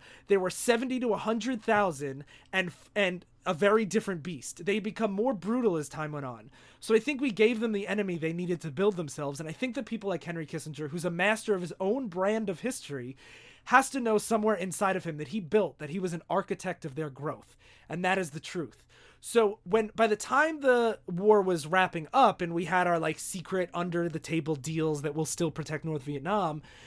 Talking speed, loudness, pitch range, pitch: 225 wpm, -30 LUFS, 160-215 Hz, 185 Hz